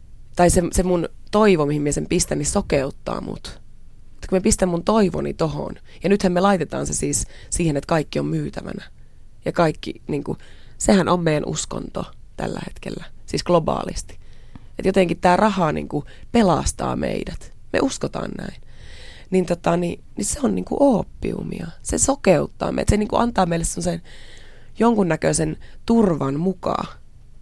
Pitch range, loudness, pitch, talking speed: 155-195 Hz, -21 LUFS, 175 Hz, 150 wpm